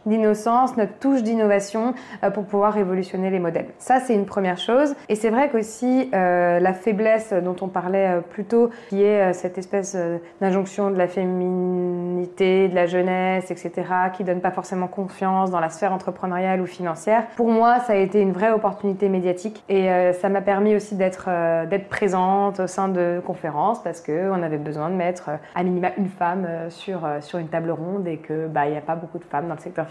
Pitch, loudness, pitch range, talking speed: 190 Hz, -22 LUFS, 180-205 Hz, 210 wpm